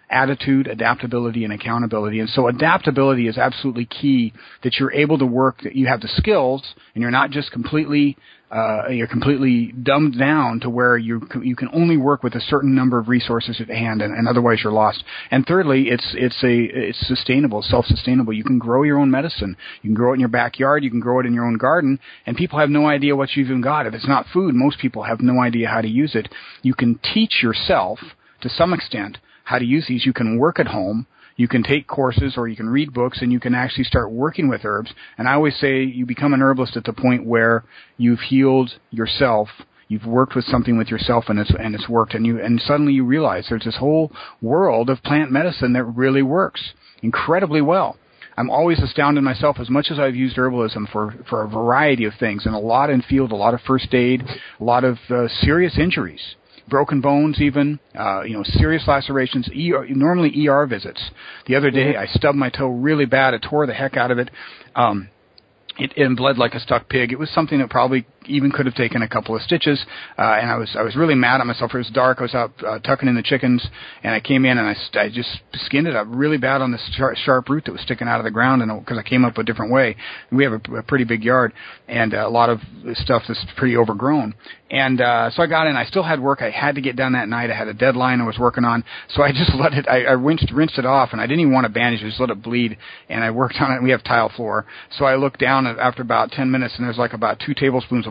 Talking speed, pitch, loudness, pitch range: 245 wpm, 125 Hz, -18 LUFS, 115-135 Hz